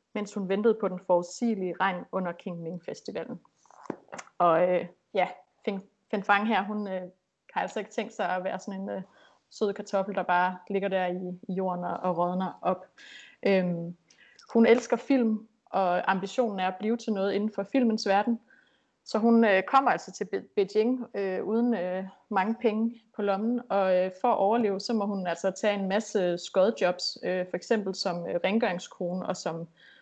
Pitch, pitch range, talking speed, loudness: 195 Hz, 185-225 Hz, 180 wpm, -28 LUFS